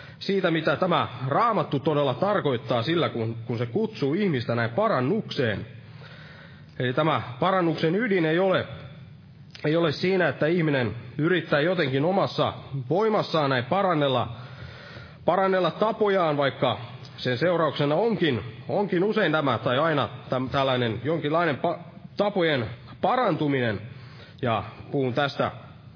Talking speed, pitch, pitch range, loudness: 120 wpm, 145 Hz, 130-170 Hz, -25 LUFS